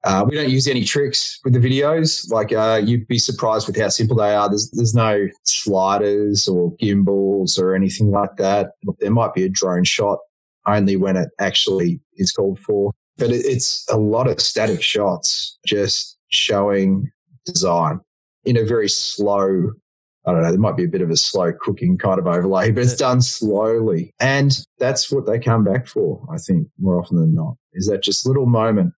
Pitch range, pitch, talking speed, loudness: 100-135 Hz, 110 Hz, 195 wpm, -18 LUFS